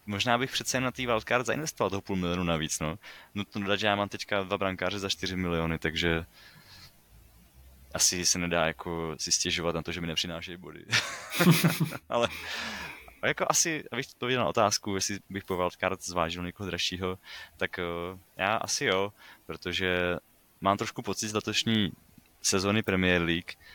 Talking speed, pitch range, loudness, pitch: 165 wpm, 85-100 Hz, -29 LUFS, 95 Hz